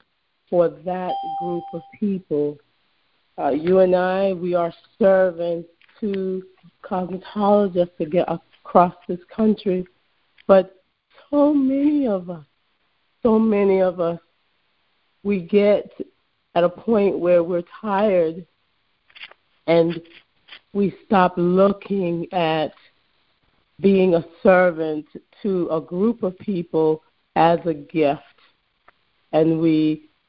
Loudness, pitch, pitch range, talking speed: -20 LUFS, 180 Hz, 170-195 Hz, 105 wpm